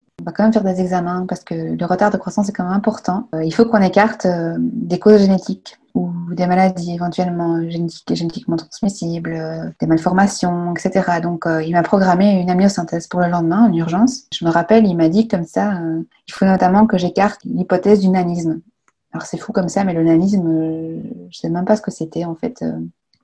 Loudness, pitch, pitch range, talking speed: -17 LUFS, 180 Hz, 170-200 Hz, 200 wpm